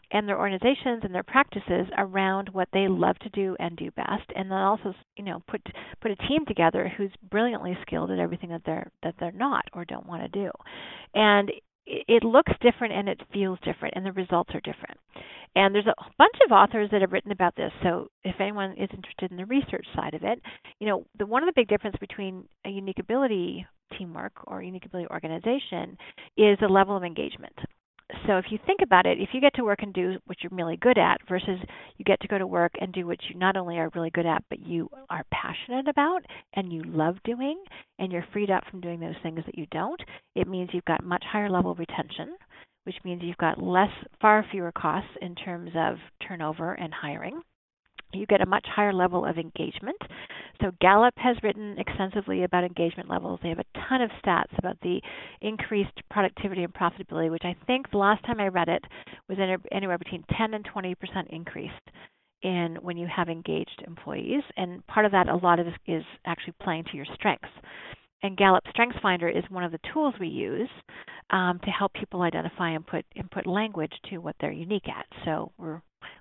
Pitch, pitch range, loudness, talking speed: 190 Hz, 175-210 Hz, -27 LUFS, 210 wpm